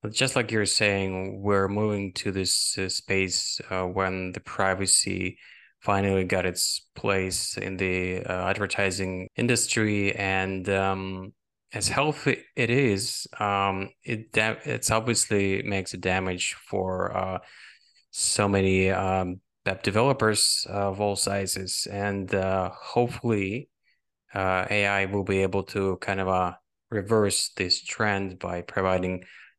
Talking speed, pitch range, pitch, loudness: 135 wpm, 95-105 Hz, 95 Hz, -26 LUFS